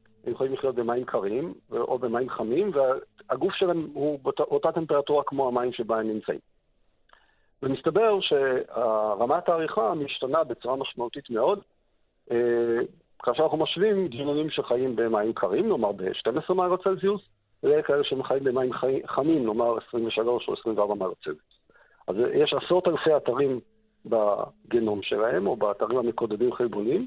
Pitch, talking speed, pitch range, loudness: 145 Hz, 130 wpm, 120-190 Hz, -26 LUFS